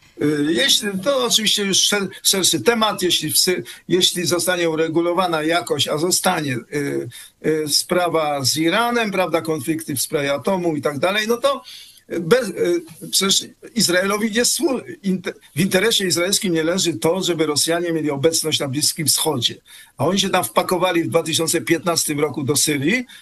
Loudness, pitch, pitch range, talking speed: -18 LUFS, 170 Hz, 155-190 Hz, 155 wpm